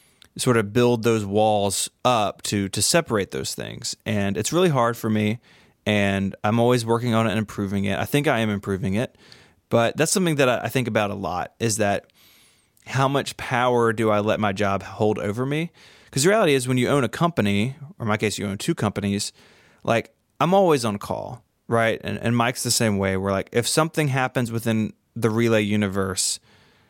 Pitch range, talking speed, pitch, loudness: 105-125 Hz, 205 wpm, 115 Hz, -22 LUFS